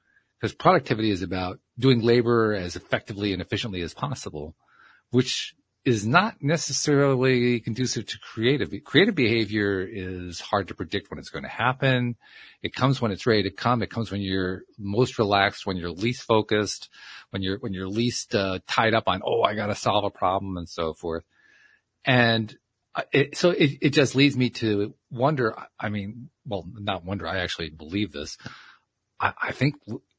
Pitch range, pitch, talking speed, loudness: 95-125 Hz, 110 Hz, 175 wpm, -25 LUFS